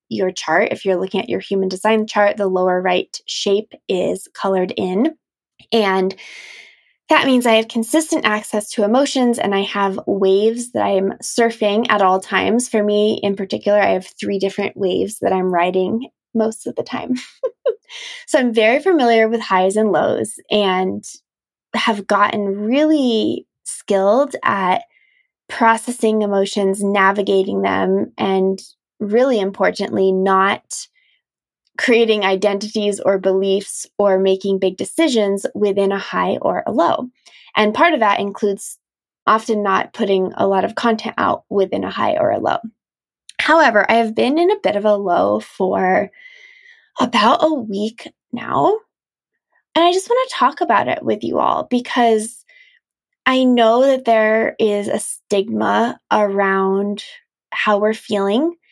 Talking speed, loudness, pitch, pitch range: 150 wpm, -17 LUFS, 215 Hz, 195-255 Hz